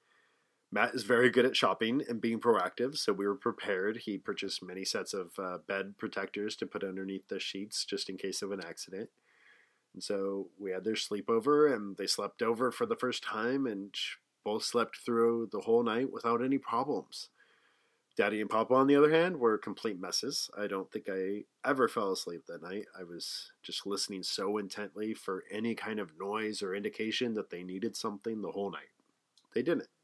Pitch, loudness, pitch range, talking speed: 105 Hz, -33 LUFS, 95-115 Hz, 195 wpm